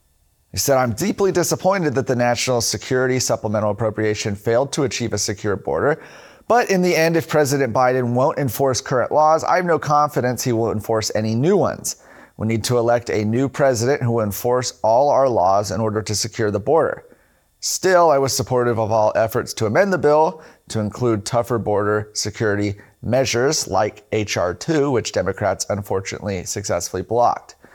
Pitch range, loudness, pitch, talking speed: 110-135 Hz, -19 LUFS, 120 Hz, 175 wpm